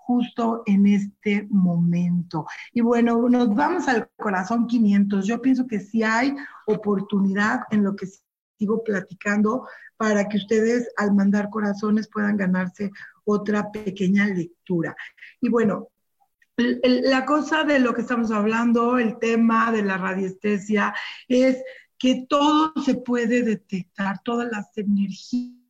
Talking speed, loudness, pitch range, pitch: 130 wpm, -22 LUFS, 200-245 Hz, 220 Hz